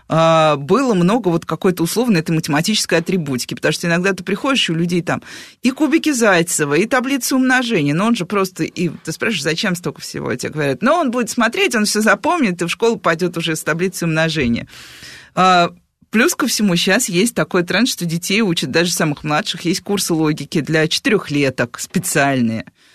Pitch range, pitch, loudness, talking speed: 160-215 Hz, 175 Hz, -16 LUFS, 185 wpm